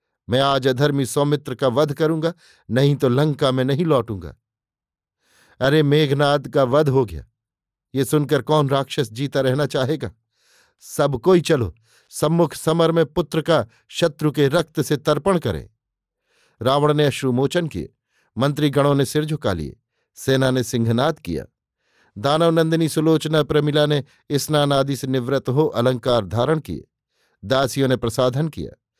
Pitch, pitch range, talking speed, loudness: 140 Hz, 130-155 Hz, 145 wpm, -20 LUFS